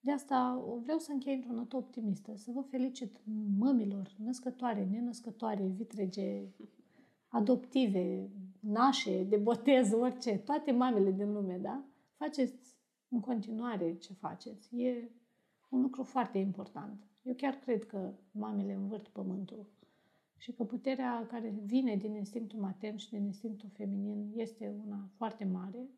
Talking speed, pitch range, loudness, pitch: 135 wpm, 205-250 Hz, -36 LUFS, 225 Hz